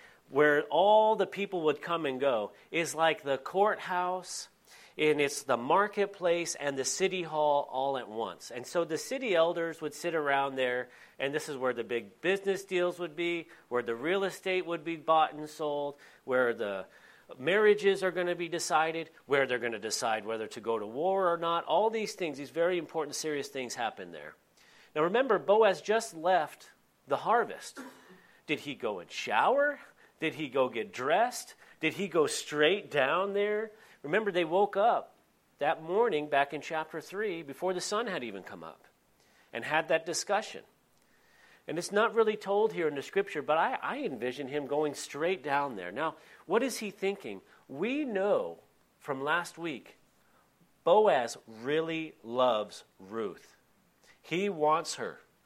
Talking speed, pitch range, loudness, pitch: 175 wpm, 140-195 Hz, -31 LUFS, 165 Hz